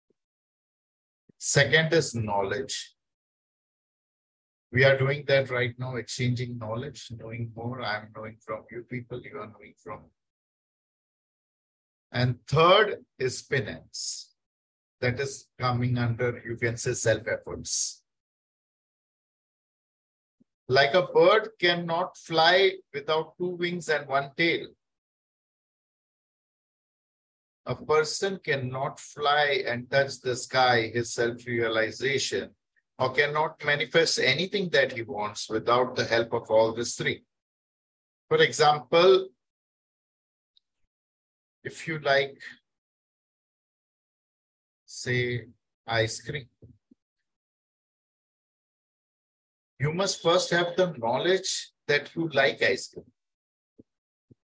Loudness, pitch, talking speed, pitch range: -25 LUFS, 125 Hz, 100 wpm, 115-155 Hz